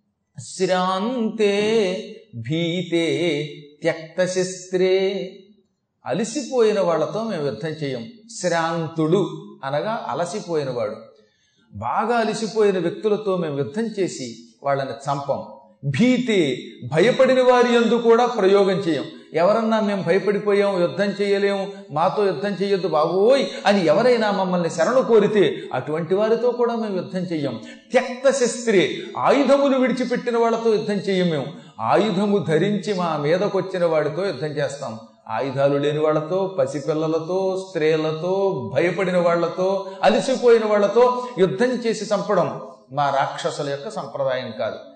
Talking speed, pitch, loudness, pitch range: 105 wpm, 190 Hz, -21 LUFS, 160-220 Hz